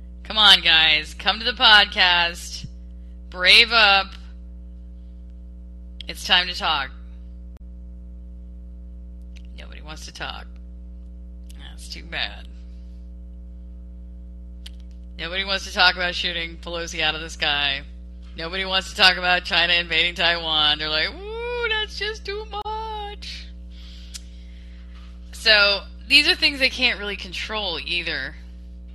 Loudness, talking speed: -18 LUFS, 115 wpm